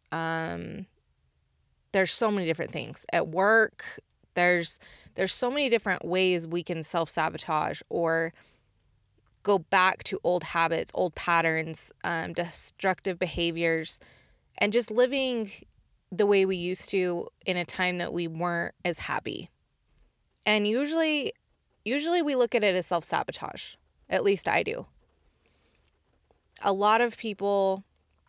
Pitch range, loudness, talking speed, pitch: 165-200 Hz, -27 LUFS, 135 wpm, 175 Hz